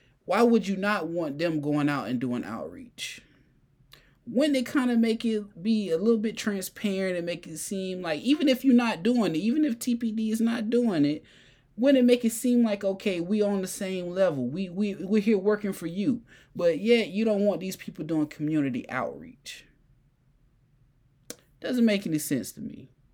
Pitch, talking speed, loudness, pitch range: 200 Hz, 195 wpm, -27 LUFS, 155-230 Hz